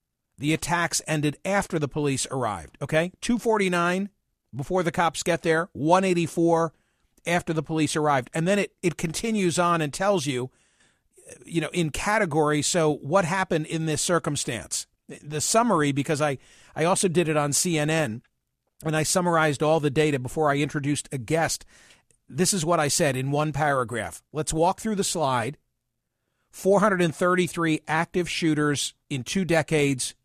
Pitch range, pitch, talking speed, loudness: 150-175 Hz, 160 Hz, 155 wpm, -24 LUFS